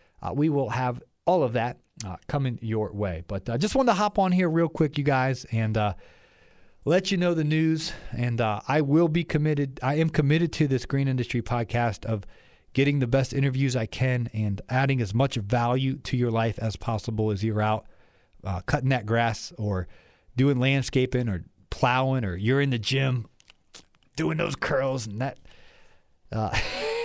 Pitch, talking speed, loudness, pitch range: 125 Hz, 190 wpm, -26 LUFS, 110-140 Hz